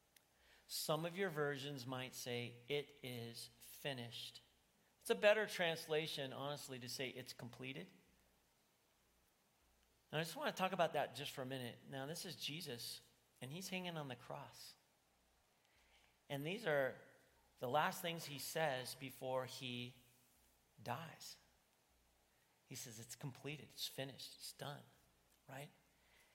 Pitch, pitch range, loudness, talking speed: 135 Hz, 125-155 Hz, -45 LUFS, 135 wpm